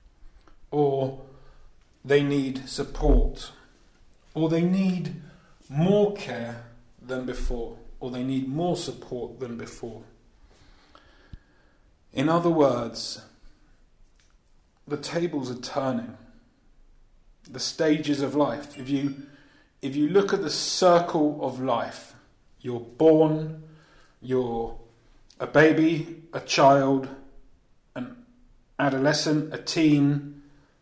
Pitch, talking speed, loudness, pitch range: 140 Hz, 95 wpm, -25 LUFS, 125-155 Hz